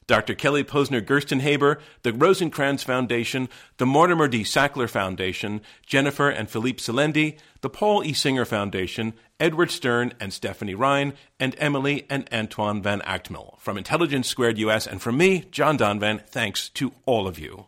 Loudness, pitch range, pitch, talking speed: -23 LUFS, 110-145 Hz, 125 Hz, 155 wpm